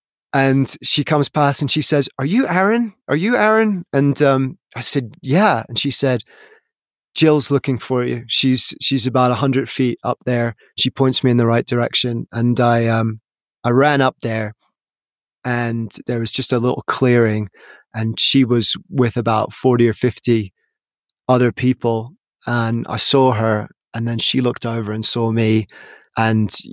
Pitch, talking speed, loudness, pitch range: 125 Hz, 175 wpm, -16 LUFS, 115-140 Hz